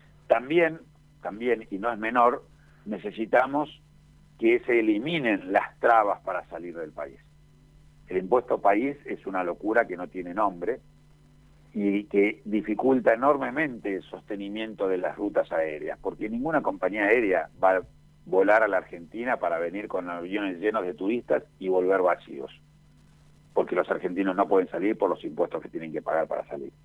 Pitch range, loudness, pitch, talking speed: 95-150 Hz, -26 LUFS, 110 Hz, 160 wpm